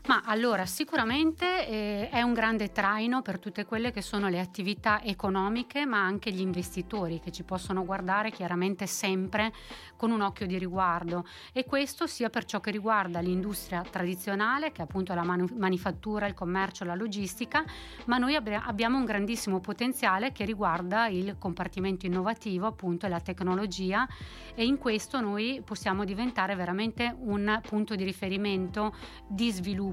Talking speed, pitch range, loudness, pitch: 160 wpm, 190-225 Hz, -30 LUFS, 205 Hz